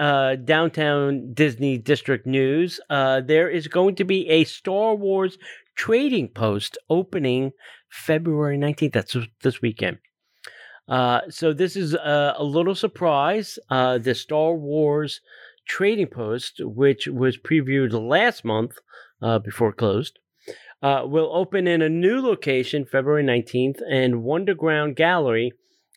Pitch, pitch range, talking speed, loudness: 145 Hz, 130-170 Hz, 130 wpm, -22 LUFS